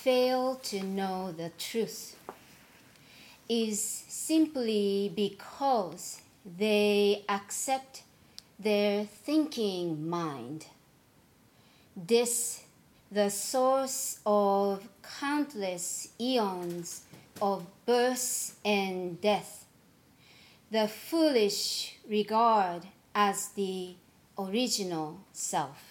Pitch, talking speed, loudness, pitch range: 205 Hz, 70 wpm, -30 LUFS, 195-235 Hz